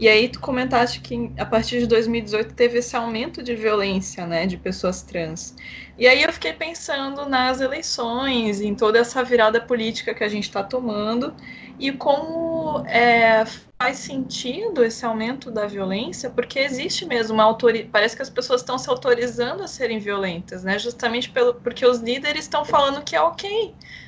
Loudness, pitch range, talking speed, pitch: -21 LUFS, 220-265 Hz, 175 wpm, 240 Hz